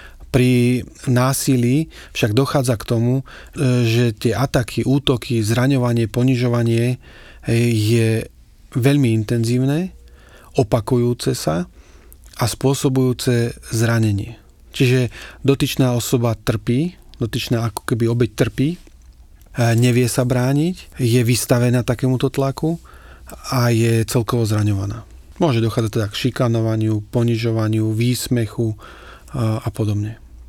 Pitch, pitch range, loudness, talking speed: 120 Hz, 115-130 Hz, -19 LUFS, 95 wpm